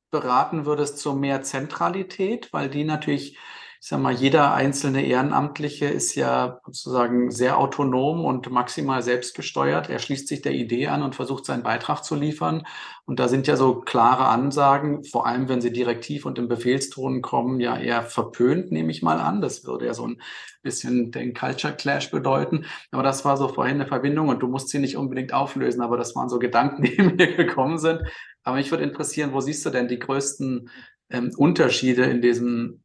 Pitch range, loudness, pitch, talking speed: 125-140 Hz, -23 LUFS, 130 Hz, 190 wpm